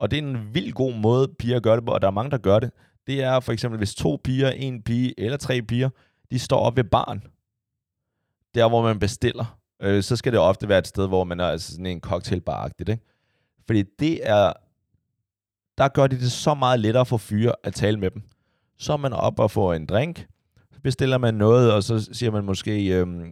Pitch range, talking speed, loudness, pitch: 105-130 Hz, 230 wpm, -23 LUFS, 115 Hz